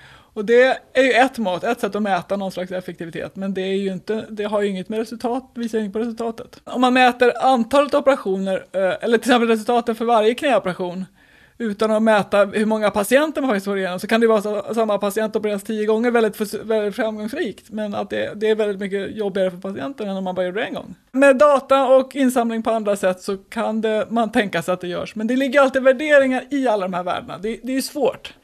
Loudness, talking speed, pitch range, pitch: -19 LUFS, 240 wpm, 200-245 Hz, 220 Hz